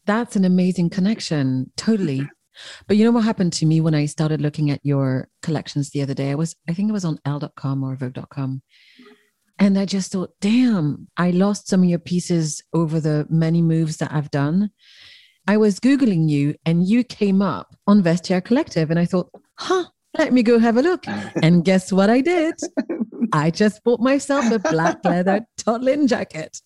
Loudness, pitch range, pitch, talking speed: -20 LUFS, 155-215 Hz, 180 Hz, 190 wpm